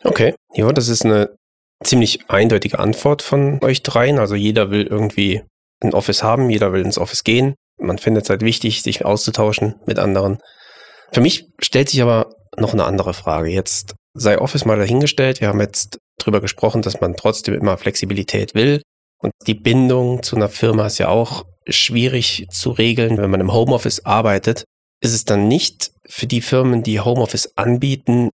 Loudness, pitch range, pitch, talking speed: -16 LUFS, 100-125 Hz, 110 Hz, 180 wpm